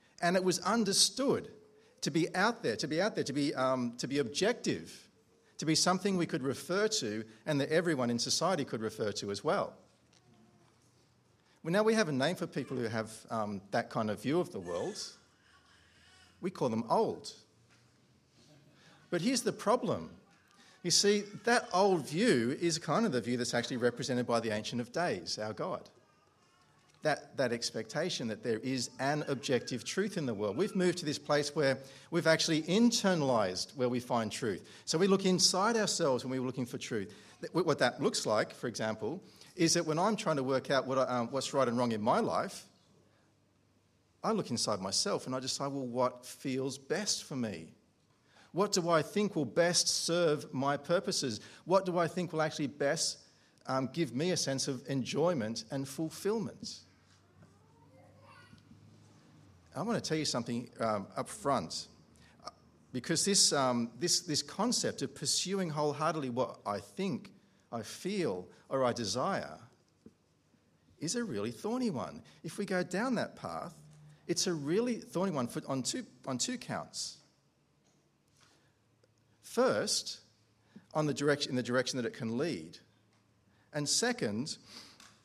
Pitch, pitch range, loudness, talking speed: 145 Hz, 125-180 Hz, -33 LUFS, 170 wpm